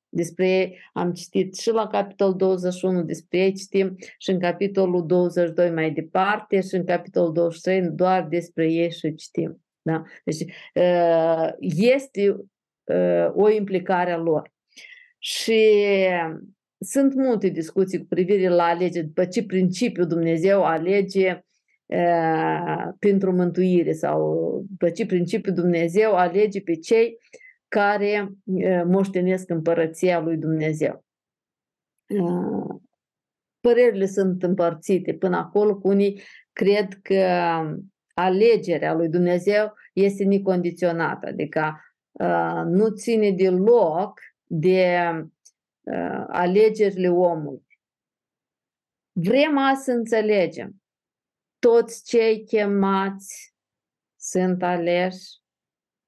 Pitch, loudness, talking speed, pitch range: 185 Hz, -22 LUFS, 95 wpm, 170-200 Hz